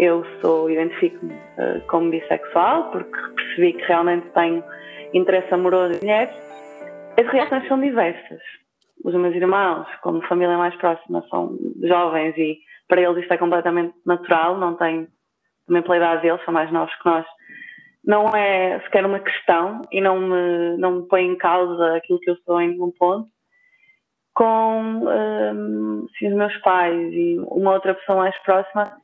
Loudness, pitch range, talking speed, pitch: -20 LUFS, 170-195 Hz, 160 wpm, 175 Hz